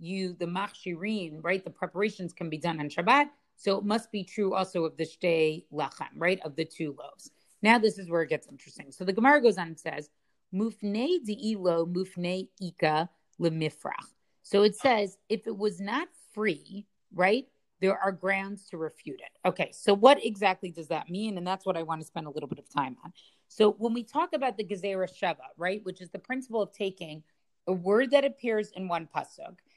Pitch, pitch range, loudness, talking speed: 190 Hz, 165-210 Hz, -29 LUFS, 205 wpm